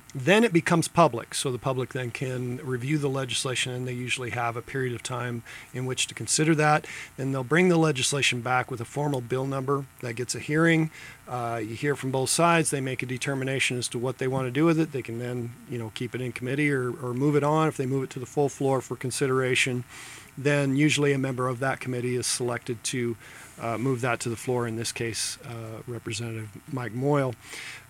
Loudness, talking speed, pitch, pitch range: -26 LUFS, 230 wpm, 130 Hz, 120-140 Hz